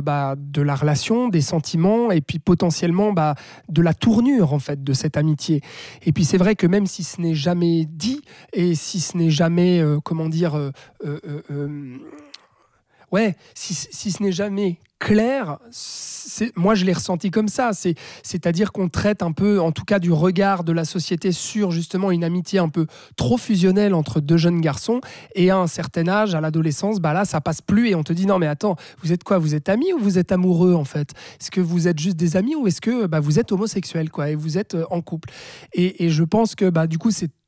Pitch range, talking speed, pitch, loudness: 160-200 Hz, 225 wpm, 175 Hz, -20 LUFS